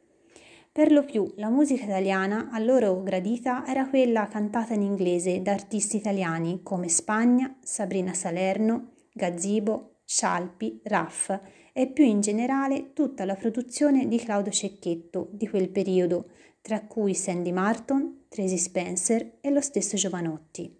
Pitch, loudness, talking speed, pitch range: 210 Hz, -26 LUFS, 135 wpm, 185-245 Hz